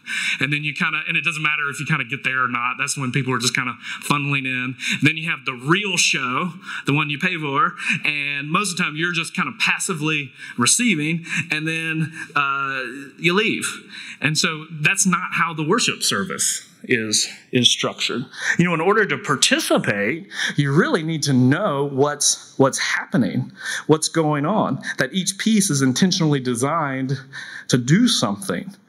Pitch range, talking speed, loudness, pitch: 140-170 Hz, 190 wpm, -20 LUFS, 155 Hz